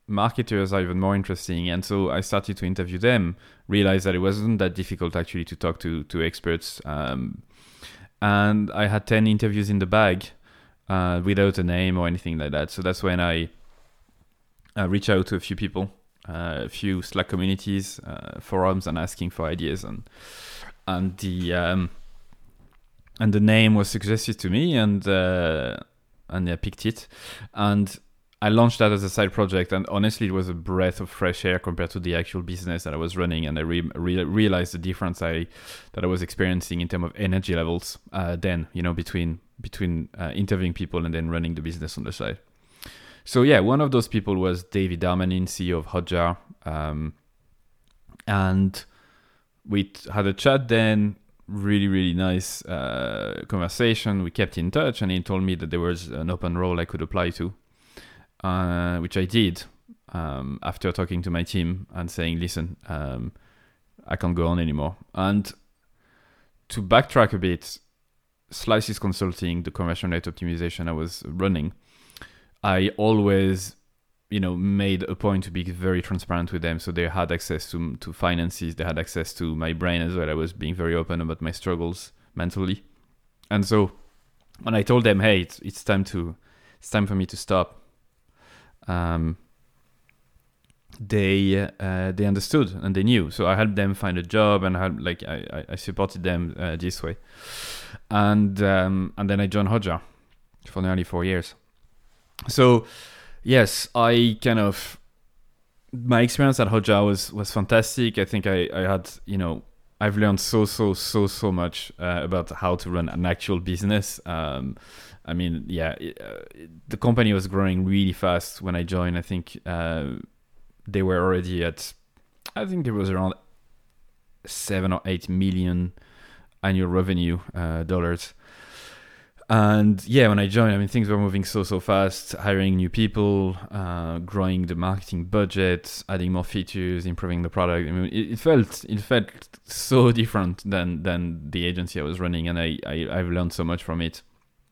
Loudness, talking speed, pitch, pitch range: -24 LUFS, 180 wpm, 95 Hz, 85-100 Hz